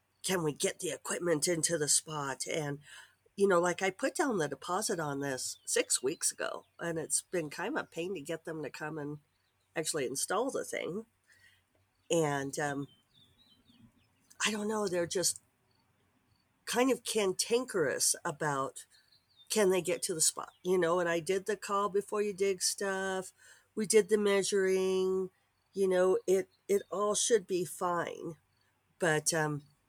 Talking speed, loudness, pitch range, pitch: 165 wpm, -32 LUFS, 150-200 Hz, 175 Hz